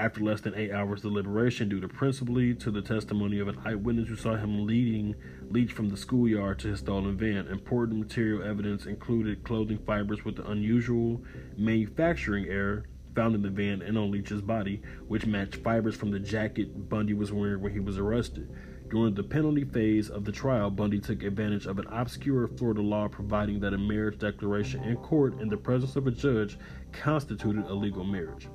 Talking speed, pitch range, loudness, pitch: 190 wpm, 100-115 Hz, -30 LUFS, 105 Hz